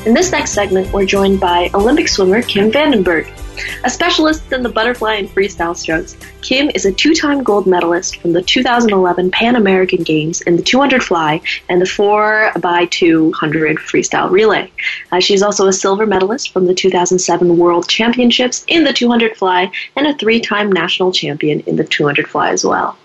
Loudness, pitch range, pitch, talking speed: -13 LUFS, 180-240 Hz, 195 Hz, 175 wpm